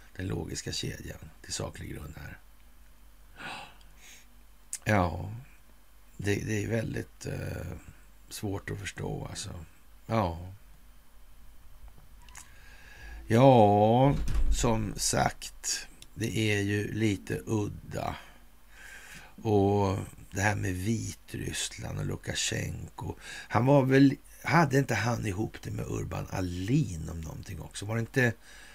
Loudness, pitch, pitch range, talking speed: -29 LUFS, 100 Hz, 85-115 Hz, 100 wpm